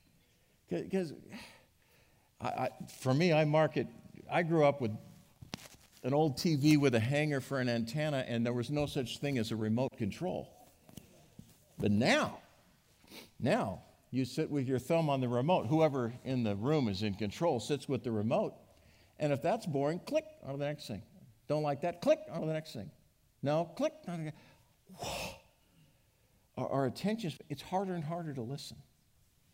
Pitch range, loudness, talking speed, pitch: 125-165 Hz, -34 LUFS, 170 wpm, 145 Hz